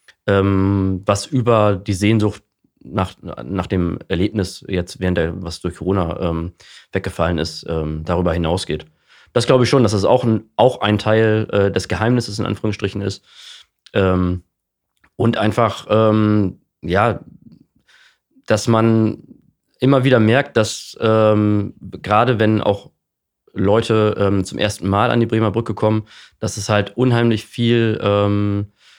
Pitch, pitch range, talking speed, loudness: 105 Hz, 95-110 Hz, 145 wpm, -18 LUFS